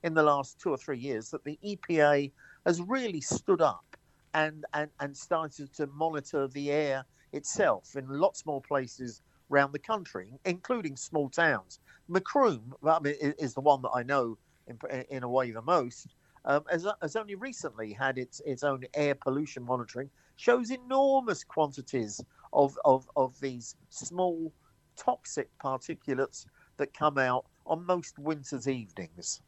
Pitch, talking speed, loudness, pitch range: 145 Hz, 160 wpm, -31 LUFS, 135-165 Hz